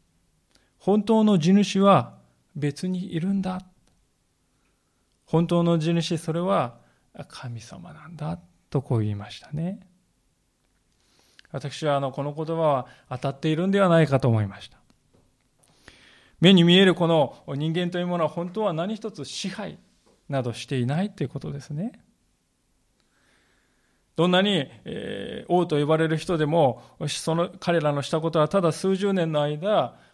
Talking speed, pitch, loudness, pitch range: 255 characters per minute, 165 Hz, -24 LUFS, 140-185 Hz